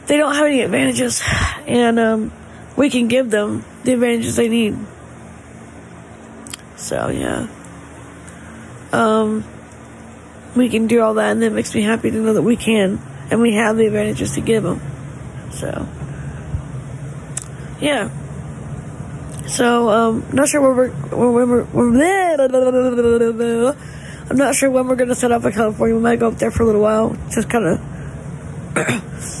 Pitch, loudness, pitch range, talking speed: 230 Hz, -17 LUFS, 220-250 Hz, 145 wpm